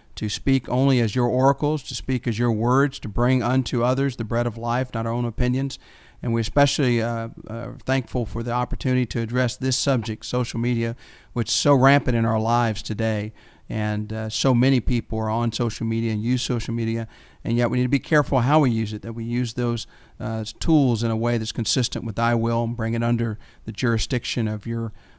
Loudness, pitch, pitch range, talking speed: -23 LUFS, 120 Hz, 115-130 Hz, 220 wpm